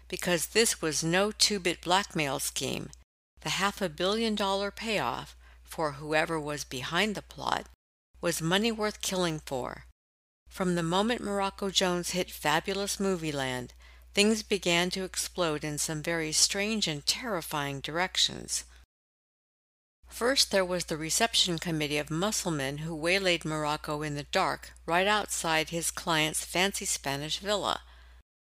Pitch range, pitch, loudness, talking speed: 145-195 Hz, 165 Hz, -29 LUFS, 135 wpm